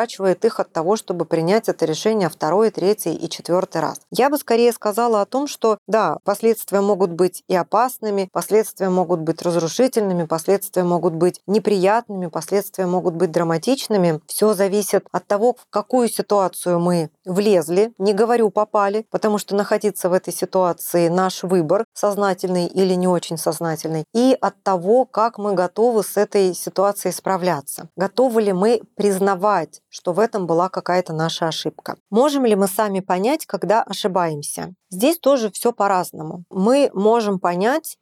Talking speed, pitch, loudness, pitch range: 155 wpm, 195 Hz, -19 LUFS, 180-215 Hz